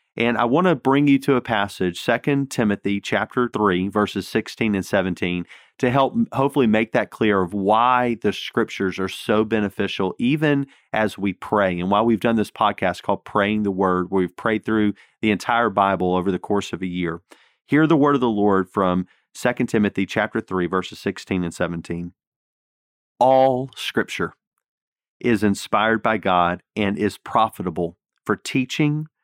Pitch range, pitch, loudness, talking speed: 95-120 Hz, 105 Hz, -21 LUFS, 170 wpm